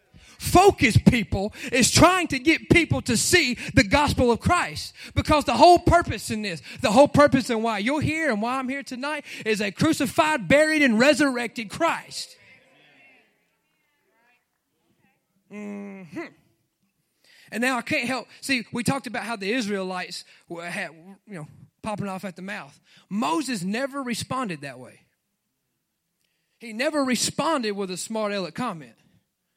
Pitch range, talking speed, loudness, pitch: 195-280 Hz, 150 wpm, -22 LUFS, 235 Hz